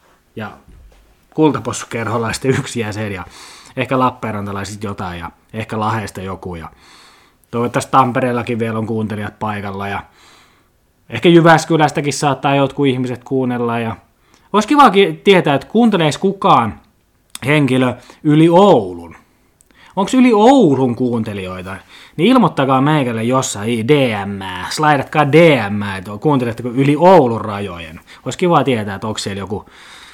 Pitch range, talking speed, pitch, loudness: 105-150 Hz, 115 wpm, 125 Hz, -14 LUFS